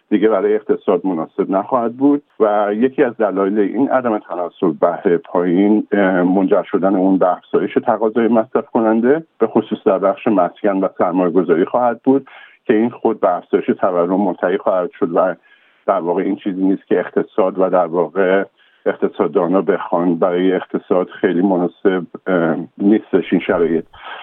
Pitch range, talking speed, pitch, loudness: 95-130 Hz, 155 wpm, 110 Hz, -16 LUFS